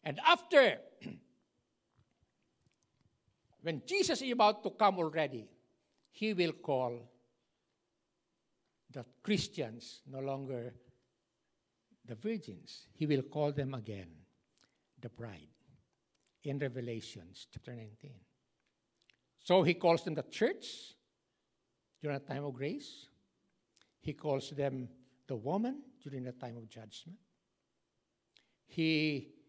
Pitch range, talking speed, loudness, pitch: 120-165 Hz, 105 wpm, -35 LUFS, 140 Hz